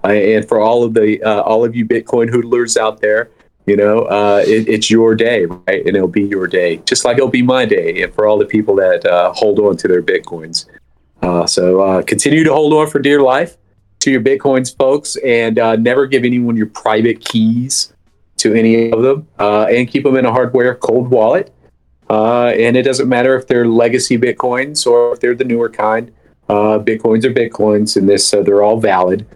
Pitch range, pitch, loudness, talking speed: 105-135 Hz, 115 Hz, -12 LUFS, 215 wpm